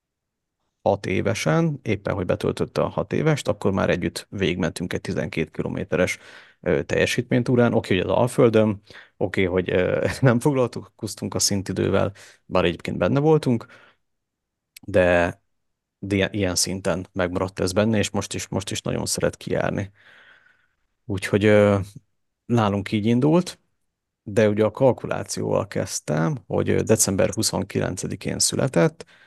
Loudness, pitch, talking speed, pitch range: -22 LUFS, 105 Hz, 125 wpm, 95-120 Hz